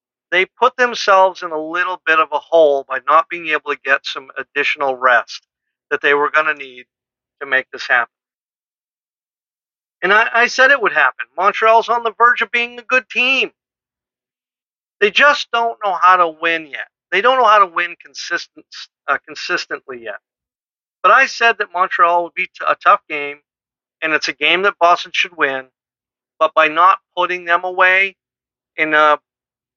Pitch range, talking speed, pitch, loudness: 150-220 Hz, 180 wpm, 175 Hz, -15 LUFS